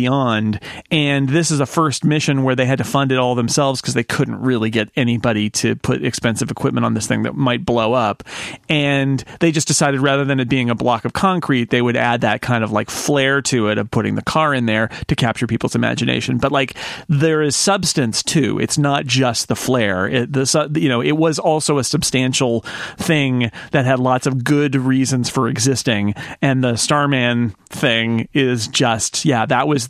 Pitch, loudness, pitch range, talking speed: 130 Hz, -17 LUFS, 120-145 Hz, 205 wpm